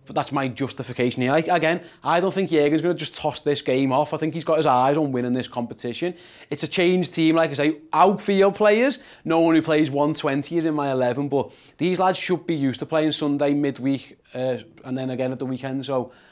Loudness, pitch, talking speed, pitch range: -22 LUFS, 150 Hz, 235 wpm, 135-165 Hz